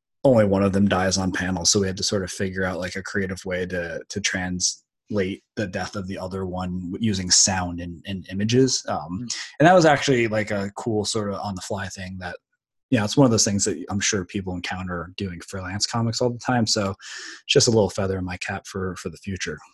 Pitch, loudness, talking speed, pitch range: 95 Hz, -23 LUFS, 245 wpm, 90-105 Hz